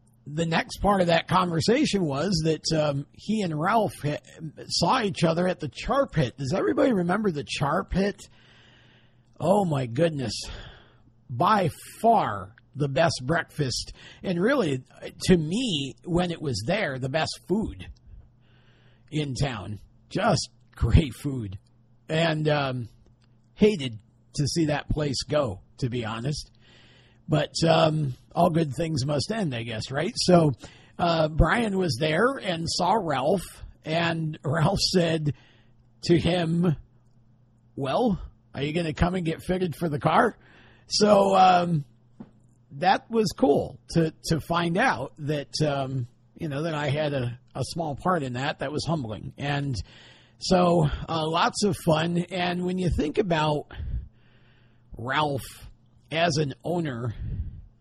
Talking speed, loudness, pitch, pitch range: 140 wpm, -25 LUFS, 150 Hz, 120-170 Hz